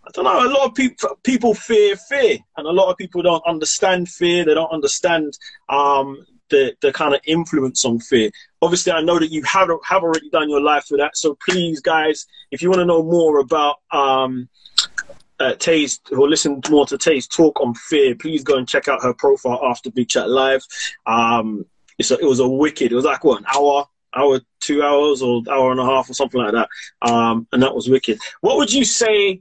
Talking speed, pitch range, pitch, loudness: 220 wpm, 135-185 Hz, 155 Hz, -17 LUFS